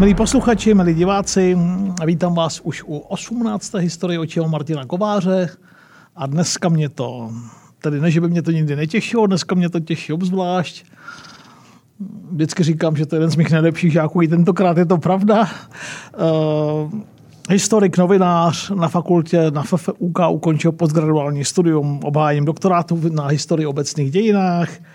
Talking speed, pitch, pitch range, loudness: 145 wpm, 170 Hz, 155-185 Hz, -17 LUFS